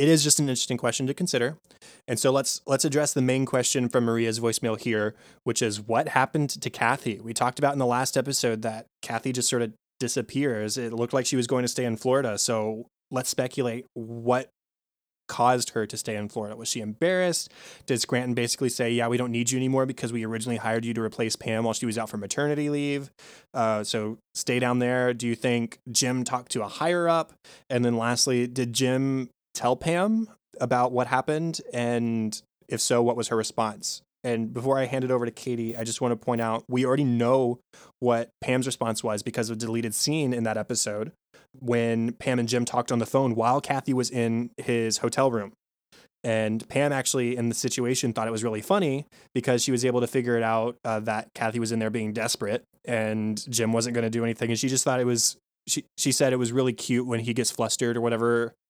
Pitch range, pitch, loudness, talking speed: 115-130 Hz, 120 Hz, -26 LUFS, 220 wpm